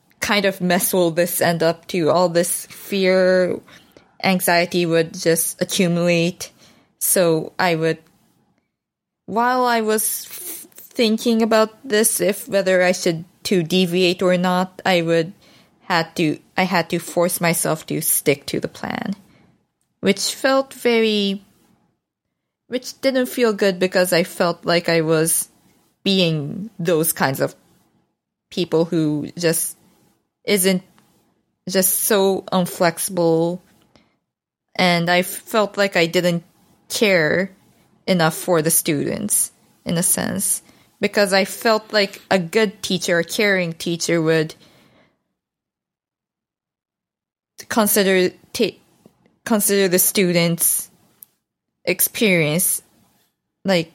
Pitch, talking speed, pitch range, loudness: 185 Hz, 115 wpm, 170-200 Hz, -19 LUFS